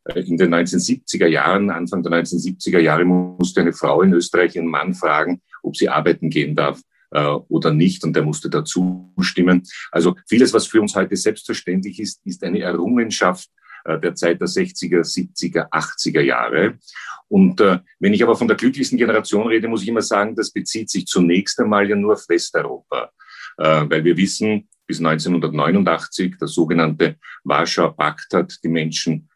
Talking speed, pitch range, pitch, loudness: 165 wpm, 85-105 Hz, 90 Hz, -18 LUFS